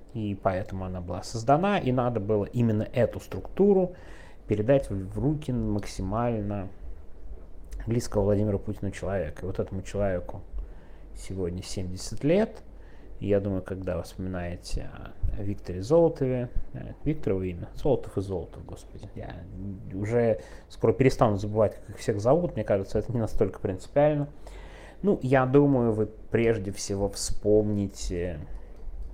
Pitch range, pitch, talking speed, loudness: 90-115 Hz, 100 Hz, 130 wpm, -28 LUFS